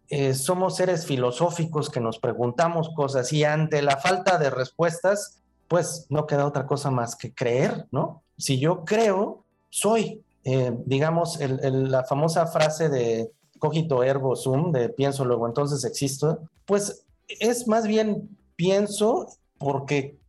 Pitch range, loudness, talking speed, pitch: 135-175 Hz, -24 LUFS, 145 wpm, 150 Hz